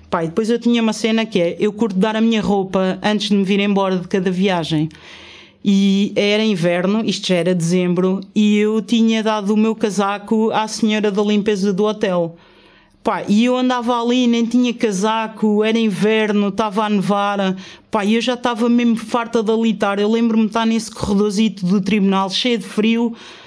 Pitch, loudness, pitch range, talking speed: 215 Hz, -17 LUFS, 200-225 Hz, 190 wpm